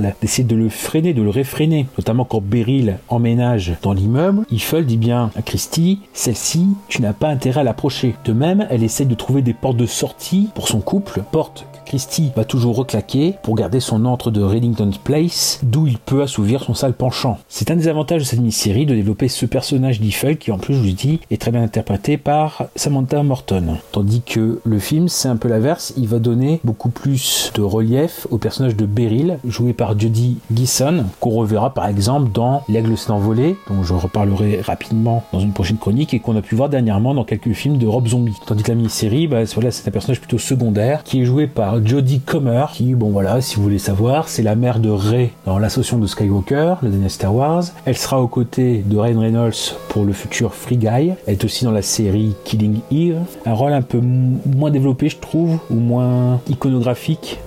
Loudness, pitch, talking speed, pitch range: -17 LUFS, 120 Hz, 210 wpm, 110-135 Hz